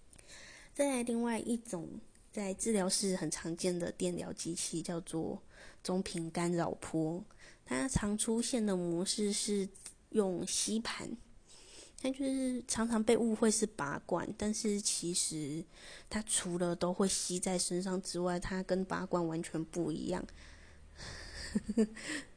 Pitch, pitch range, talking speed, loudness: 185 Hz, 170-215 Hz, 190 characters per minute, -35 LUFS